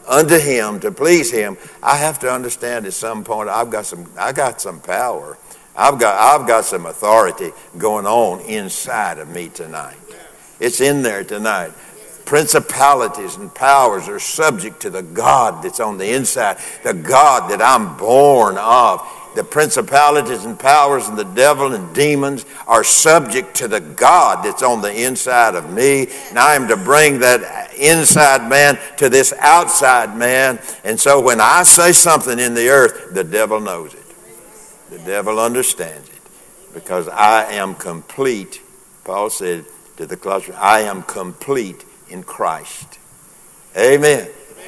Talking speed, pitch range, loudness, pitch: 155 wpm, 125-170 Hz, -13 LUFS, 140 Hz